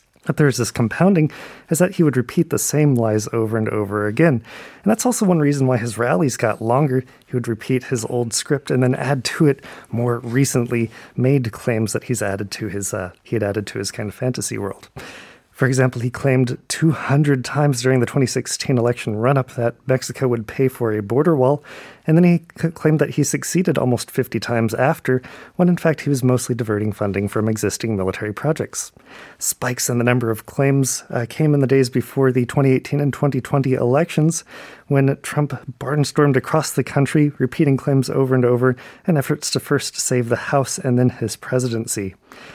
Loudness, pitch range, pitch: -19 LUFS, 120-145 Hz, 130 Hz